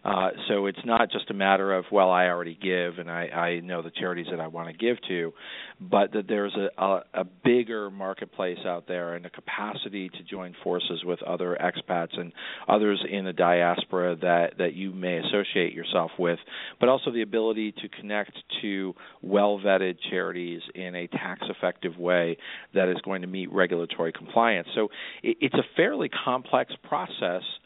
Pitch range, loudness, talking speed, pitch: 85-100 Hz, -27 LUFS, 185 wpm, 90 Hz